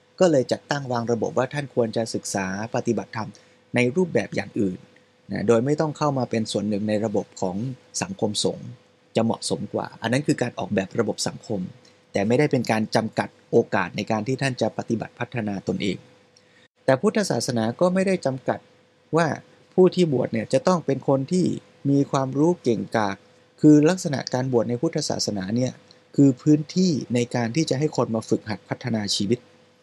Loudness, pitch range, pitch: -24 LUFS, 115-150 Hz, 125 Hz